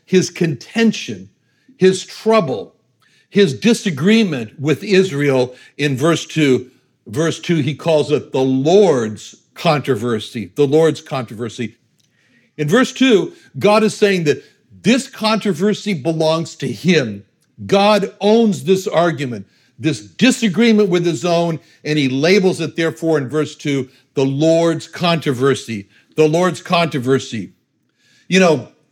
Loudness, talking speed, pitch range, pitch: -16 LUFS, 120 wpm, 135-190 Hz, 160 Hz